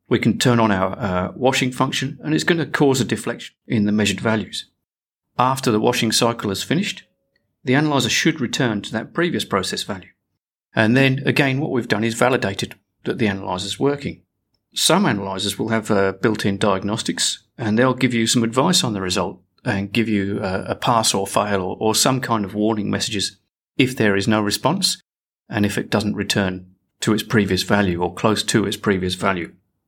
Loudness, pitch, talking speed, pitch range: -20 LUFS, 110 Hz, 200 wpm, 100-130 Hz